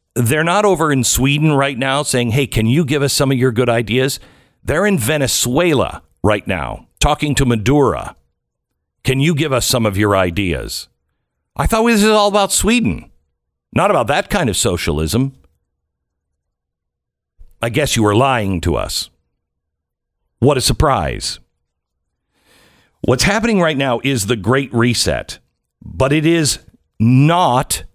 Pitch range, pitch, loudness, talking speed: 85-145 Hz, 125 Hz, -15 LUFS, 150 wpm